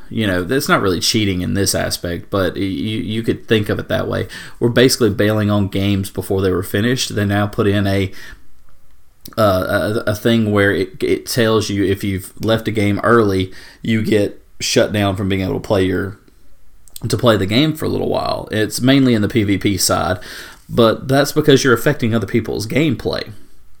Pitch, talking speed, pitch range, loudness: 105 Hz, 200 wpm, 100-115 Hz, -17 LUFS